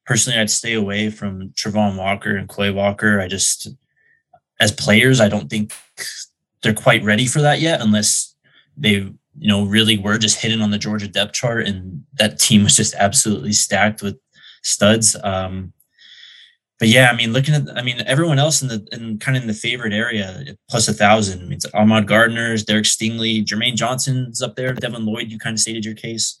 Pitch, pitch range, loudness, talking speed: 110 Hz, 105-120 Hz, -16 LUFS, 200 wpm